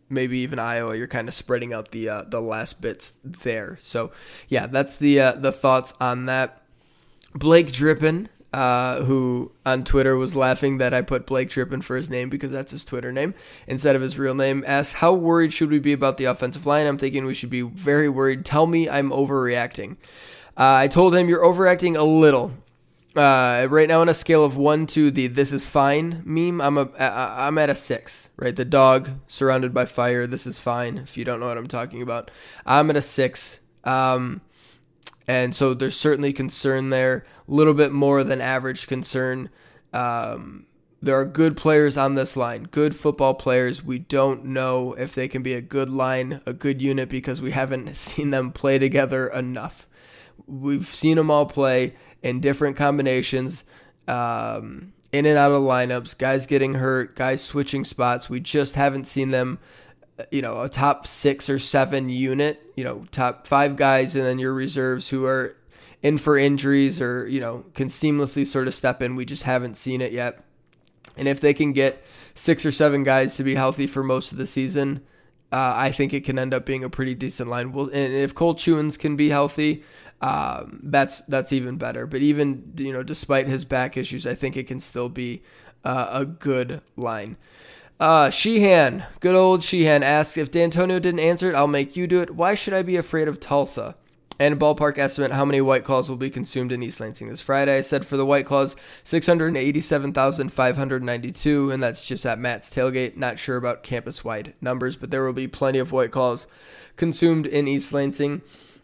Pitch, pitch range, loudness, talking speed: 135 Hz, 130-145 Hz, -22 LUFS, 200 wpm